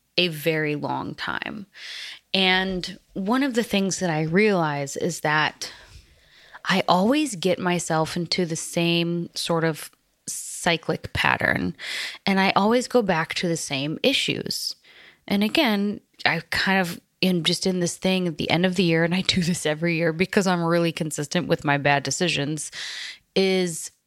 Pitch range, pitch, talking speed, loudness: 160-190 Hz, 175 Hz, 160 wpm, -23 LUFS